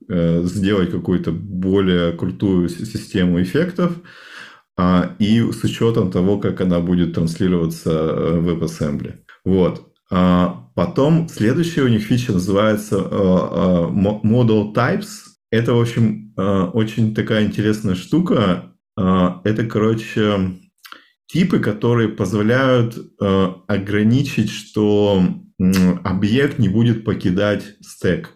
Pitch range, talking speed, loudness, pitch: 90-115 Hz, 95 wpm, -18 LUFS, 105 Hz